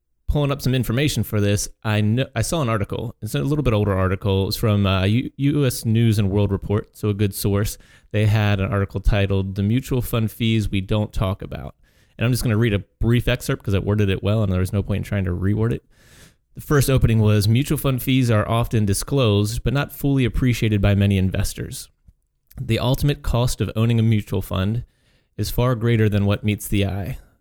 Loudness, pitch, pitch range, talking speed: -21 LUFS, 110 Hz, 100-120 Hz, 220 wpm